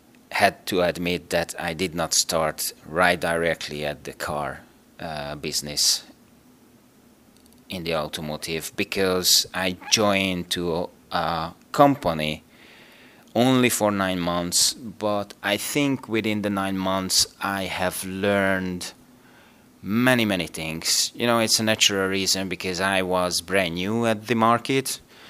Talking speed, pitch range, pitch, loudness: 130 wpm, 90-105 Hz, 95 Hz, -23 LUFS